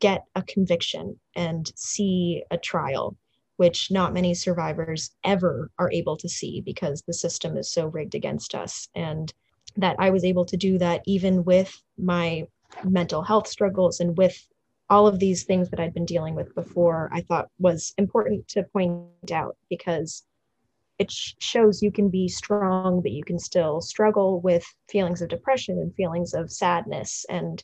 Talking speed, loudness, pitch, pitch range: 170 wpm, -25 LUFS, 180 Hz, 170-190 Hz